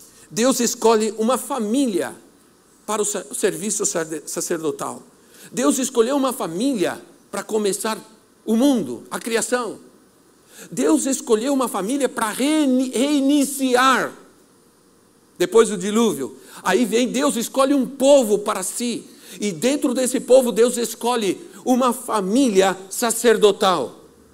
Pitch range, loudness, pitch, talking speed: 215-265 Hz, -20 LUFS, 240 Hz, 110 wpm